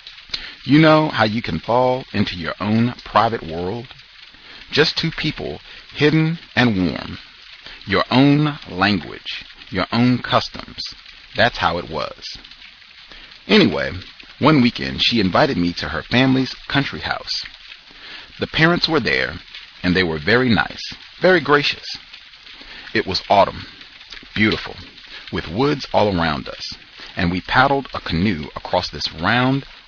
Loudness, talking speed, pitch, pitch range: -18 LUFS, 135 wpm, 120 Hz, 90-140 Hz